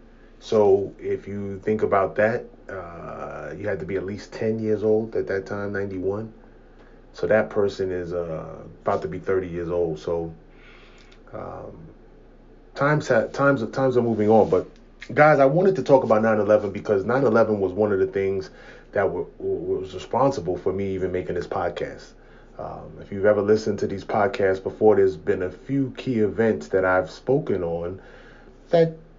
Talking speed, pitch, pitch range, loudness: 175 wpm, 110 Hz, 95-140 Hz, -23 LUFS